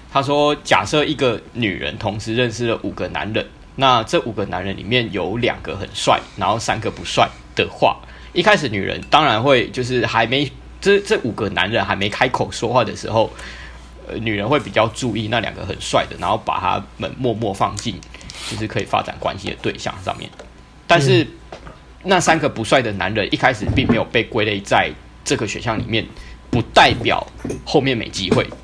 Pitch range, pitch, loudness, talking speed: 100-135 Hz, 115 Hz, -19 LUFS, 285 characters per minute